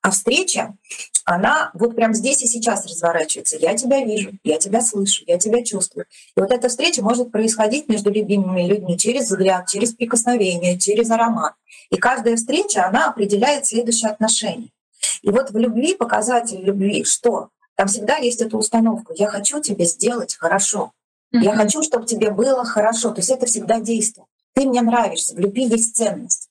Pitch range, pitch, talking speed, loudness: 205-245 Hz, 225 Hz, 170 wpm, -18 LUFS